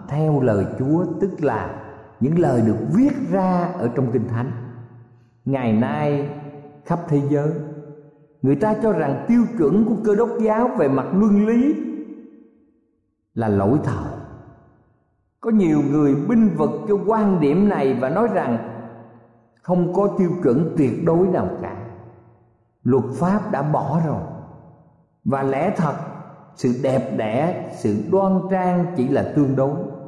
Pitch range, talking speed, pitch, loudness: 130-195 Hz, 150 wpm, 150 Hz, -20 LUFS